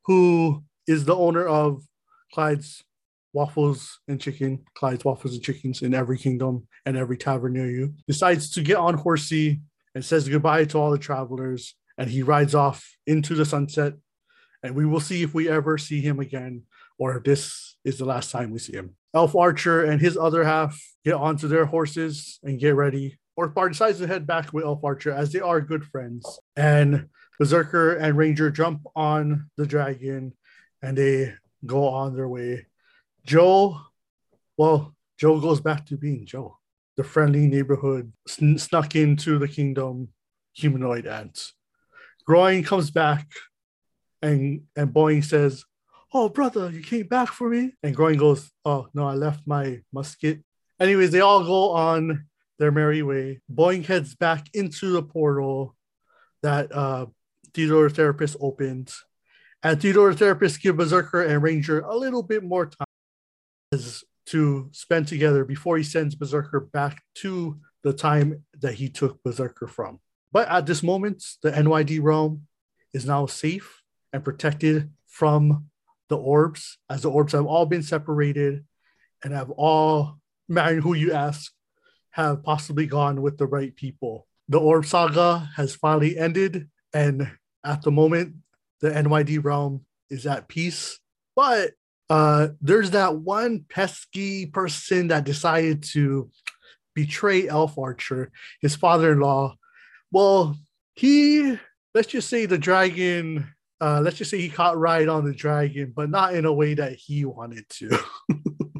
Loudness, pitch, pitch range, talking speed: -23 LUFS, 150 Hz, 140-165 Hz, 155 wpm